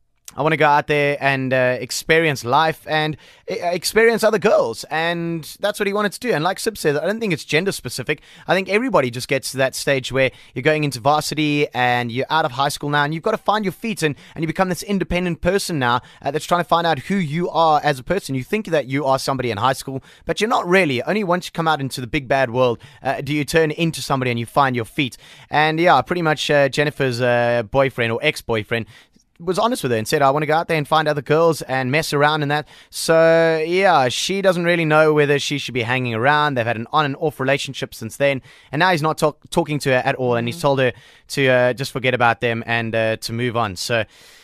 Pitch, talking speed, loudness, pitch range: 150 Hz, 260 wpm, -19 LUFS, 130-165 Hz